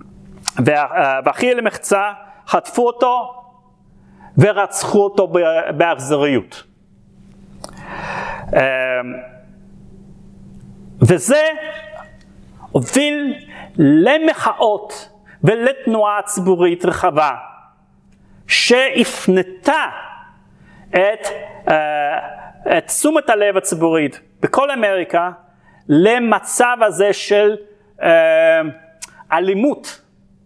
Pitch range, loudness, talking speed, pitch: 175-245 Hz, -16 LUFS, 50 wpm, 205 Hz